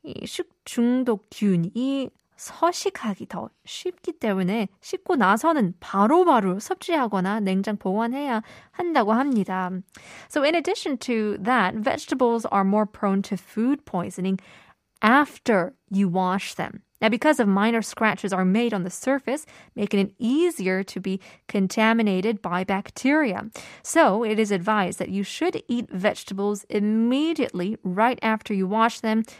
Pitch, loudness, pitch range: 220 Hz, -24 LUFS, 195-260 Hz